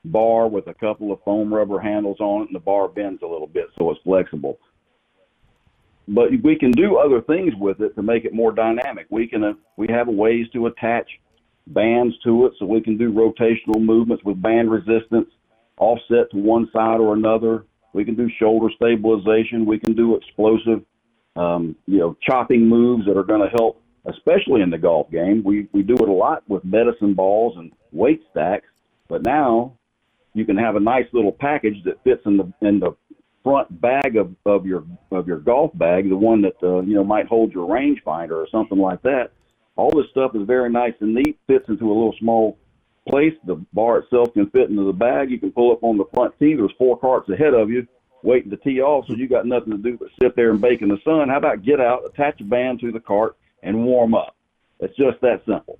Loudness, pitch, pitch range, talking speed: -19 LUFS, 115 Hz, 105-120 Hz, 220 wpm